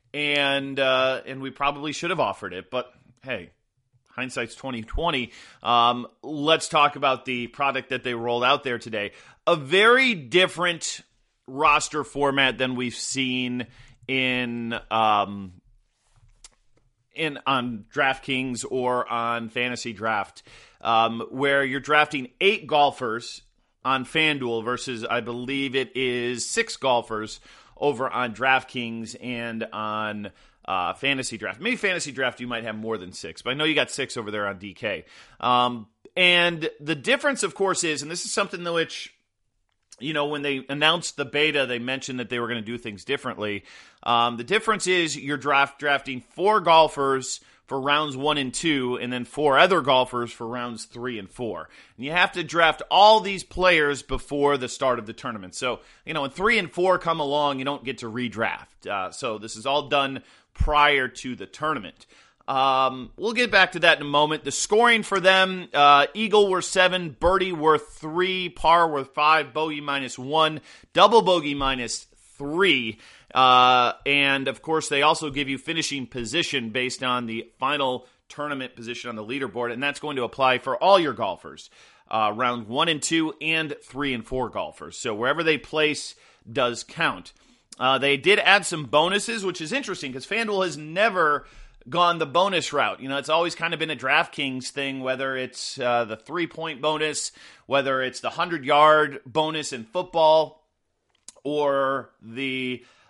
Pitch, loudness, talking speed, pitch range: 135 Hz, -23 LUFS, 170 wpm, 125-155 Hz